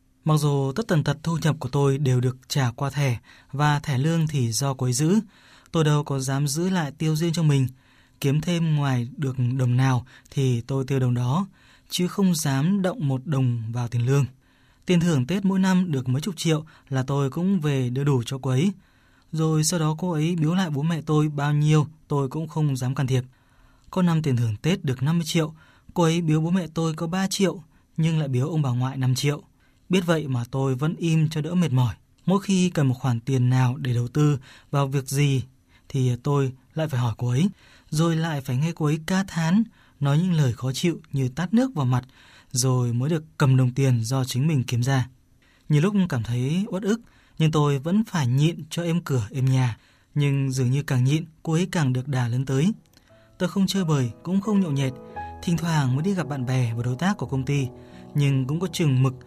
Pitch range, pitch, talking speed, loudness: 130-165 Hz, 145 Hz, 230 wpm, -24 LUFS